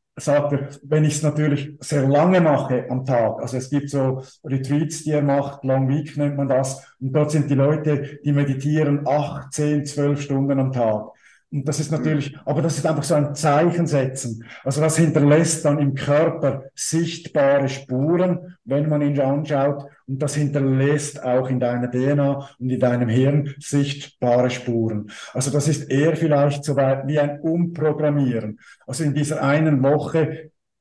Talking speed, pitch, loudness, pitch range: 175 wpm, 145 Hz, -21 LUFS, 135-150 Hz